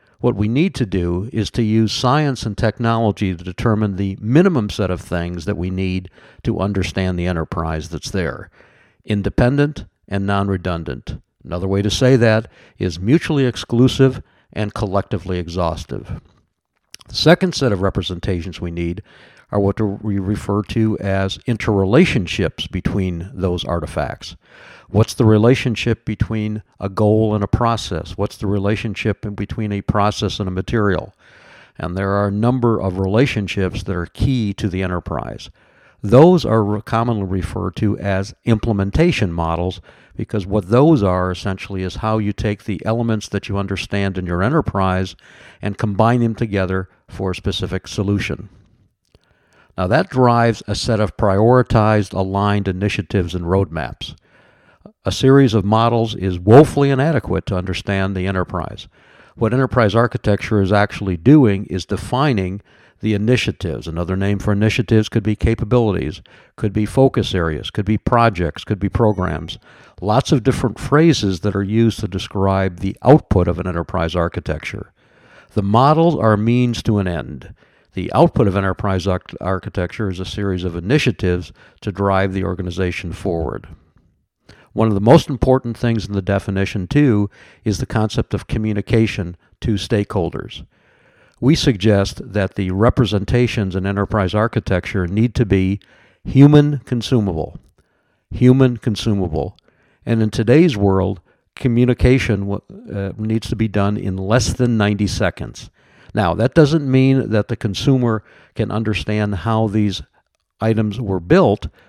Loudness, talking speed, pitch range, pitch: -18 LUFS, 145 wpm, 95-115 Hz, 105 Hz